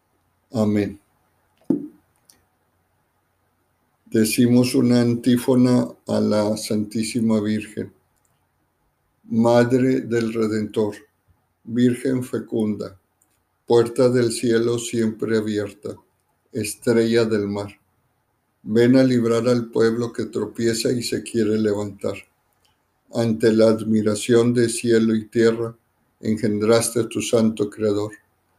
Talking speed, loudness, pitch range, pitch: 90 wpm, -20 LUFS, 105-120 Hz, 115 Hz